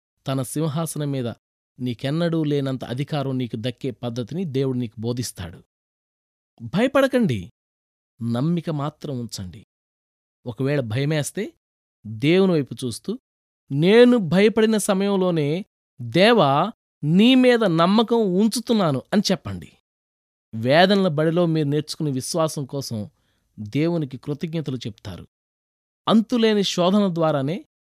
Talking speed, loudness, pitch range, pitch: 90 wpm, -21 LUFS, 120-185 Hz, 145 Hz